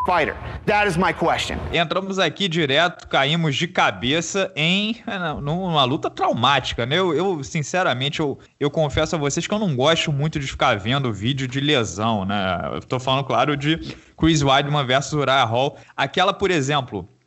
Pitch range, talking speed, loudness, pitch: 135-175 Hz, 170 wpm, -20 LUFS, 150 Hz